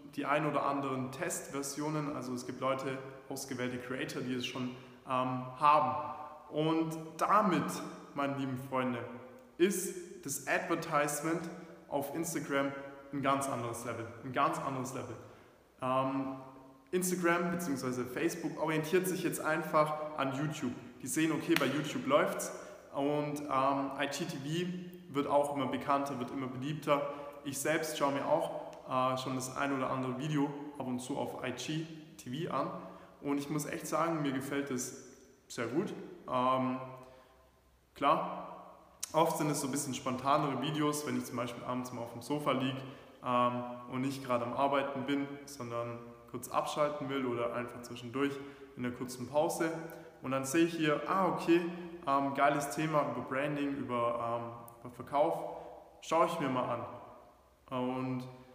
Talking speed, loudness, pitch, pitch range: 150 wpm, -35 LUFS, 140 Hz, 130-150 Hz